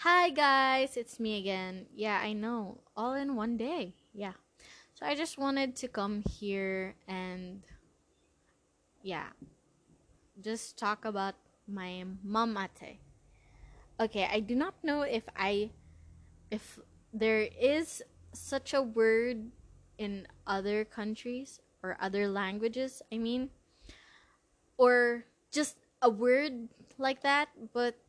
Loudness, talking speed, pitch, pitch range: -33 LUFS, 120 wpm, 225 Hz, 200-260 Hz